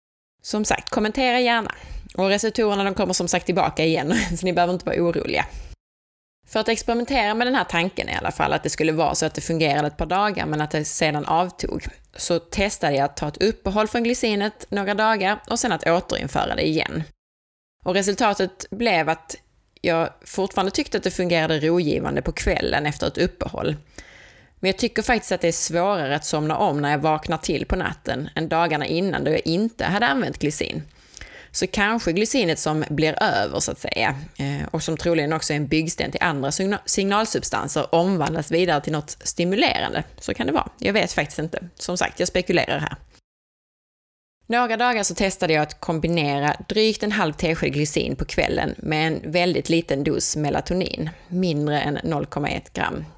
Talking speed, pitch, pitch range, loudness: 185 wpm, 175 Hz, 155-205 Hz, -22 LUFS